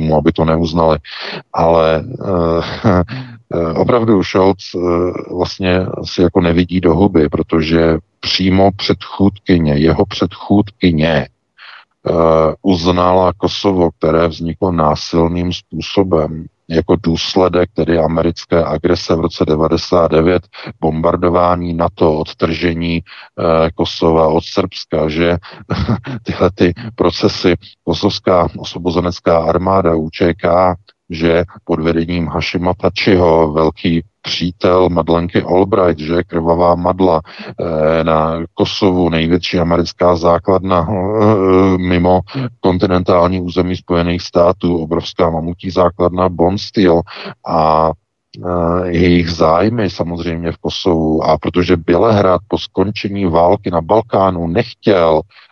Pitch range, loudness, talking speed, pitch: 85-95 Hz, -14 LUFS, 100 wpm, 85 Hz